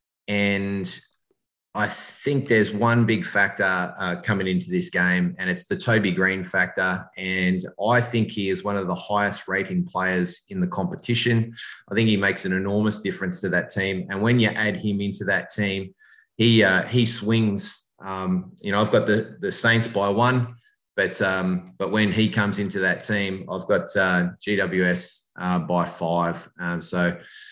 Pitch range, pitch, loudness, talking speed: 90-110 Hz, 100 Hz, -23 LUFS, 180 wpm